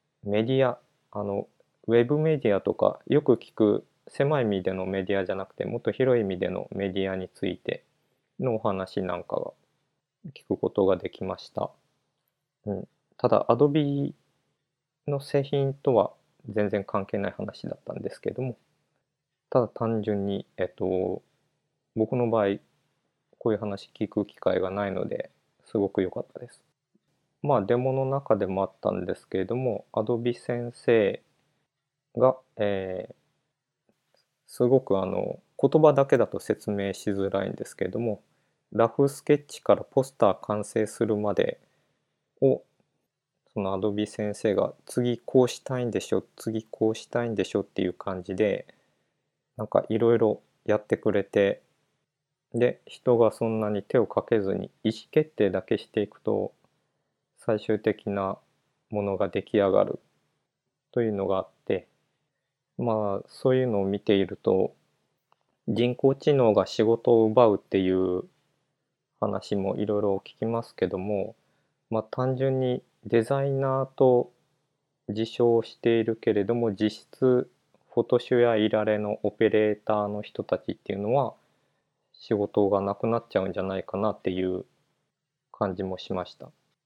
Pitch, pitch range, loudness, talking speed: 110 Hz, 100-130 Hz, -27 LUFS, 285 characters per minute